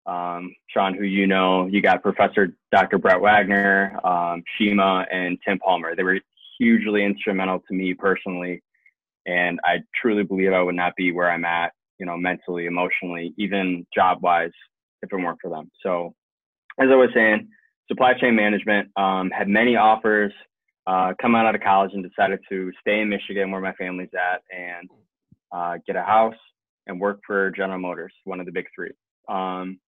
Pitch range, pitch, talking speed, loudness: 90-100 Hz, 95 Hz, 180 wpm, -21 LUFS